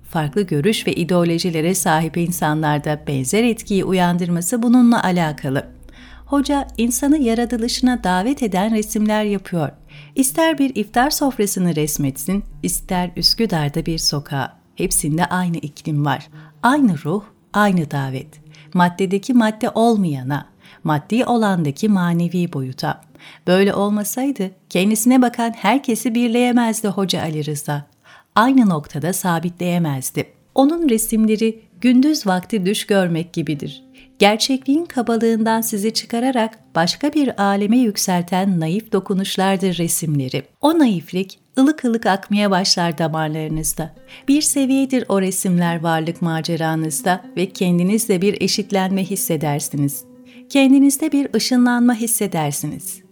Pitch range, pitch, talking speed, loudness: 165-230 Hz, 190 Hz, 105 wpm, -18 LUFS